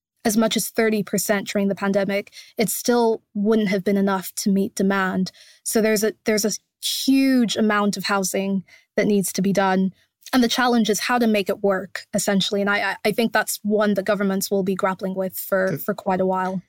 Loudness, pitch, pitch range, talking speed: -21 LUFS, 205 Hz, 195-220 Hz, 210 wpm